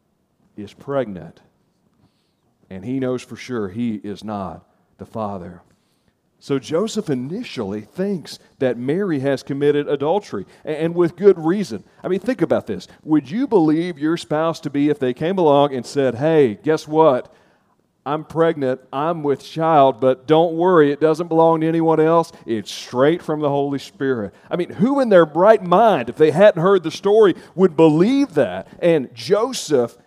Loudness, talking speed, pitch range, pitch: -18 LUFS, 170 wpm, 130-175 Hz, 155 Hz